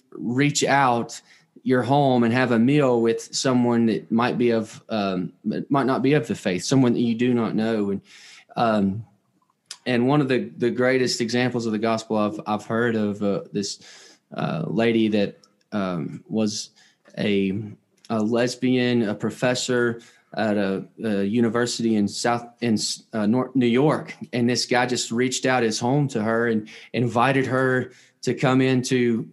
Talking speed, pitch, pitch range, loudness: 170 wpm, 120 Hz, 110-125 Hz, -22 LUFS